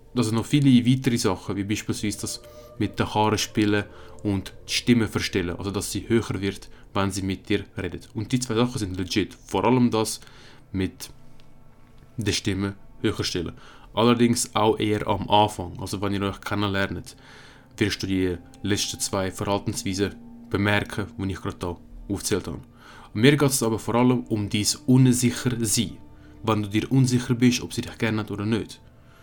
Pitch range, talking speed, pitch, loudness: 100-120 Hz, 180 wpm, 110 Hz, -24 LUFS